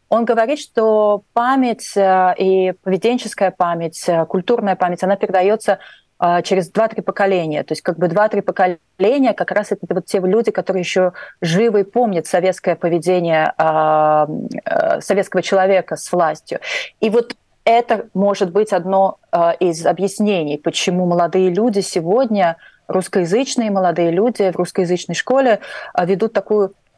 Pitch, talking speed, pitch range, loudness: 190 Hz, 125 wpm, 180-215 Hz, -17 LUFS